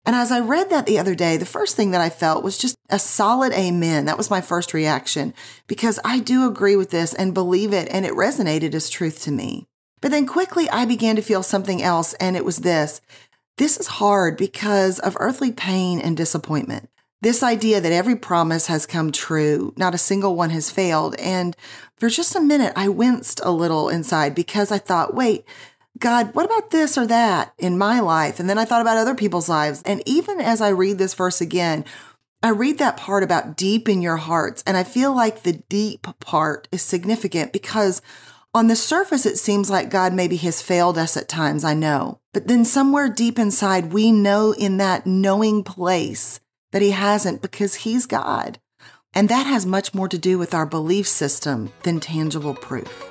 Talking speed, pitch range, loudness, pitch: 205 wpm, 170-230 Hz, -20 LUFS, 195 Hz